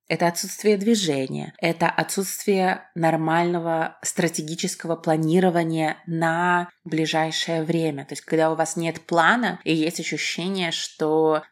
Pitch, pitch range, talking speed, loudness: 165 Hz, 160-175 Hz, 115 wpm, -23 LUFS